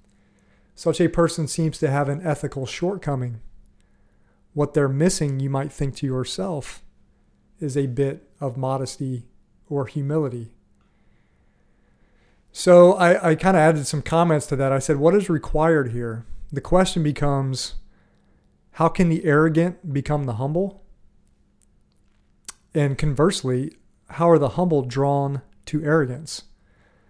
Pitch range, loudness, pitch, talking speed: 130-160 Hz, -21 LUFS, 145 Hz, 130 wpm